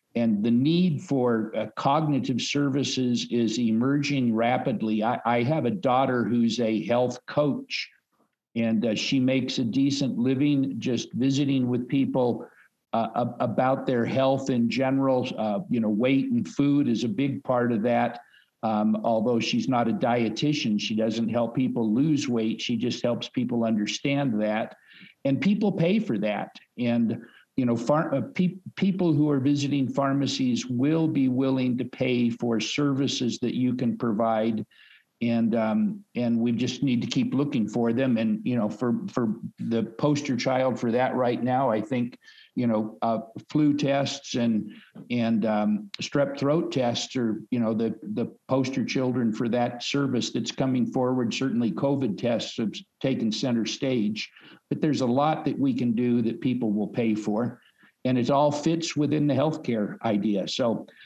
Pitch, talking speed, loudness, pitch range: 125 Hz, 170 wpm, -26 LUFS, 115-140 Hz